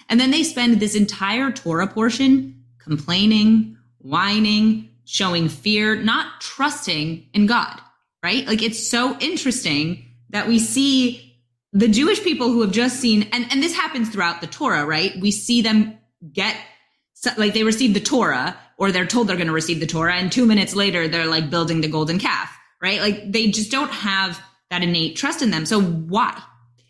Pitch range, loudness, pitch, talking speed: 170-235 Hz, -19 LUFS, 210 Hz, 180 wpm